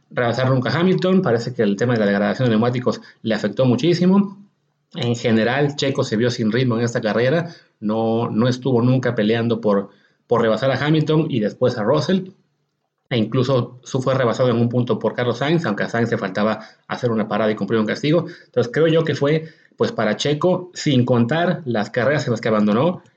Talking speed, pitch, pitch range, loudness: 205 wpm, 125 Hz, 115-155 Hz, -19 LUFS